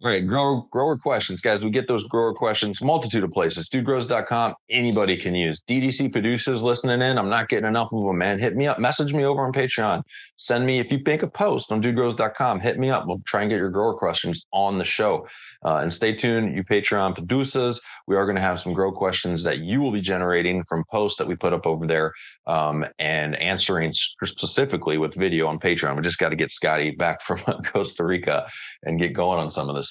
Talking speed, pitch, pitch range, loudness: 225 wpm, 110 Hz, 90-125 Hz, -23 LUFS